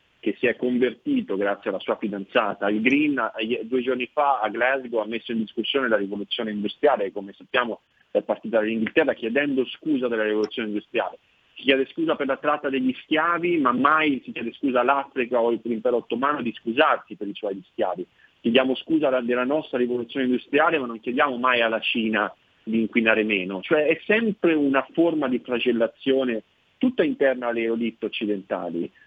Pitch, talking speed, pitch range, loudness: 125 Hz, 170 wpm, 110-140 Hz, -23 LUFS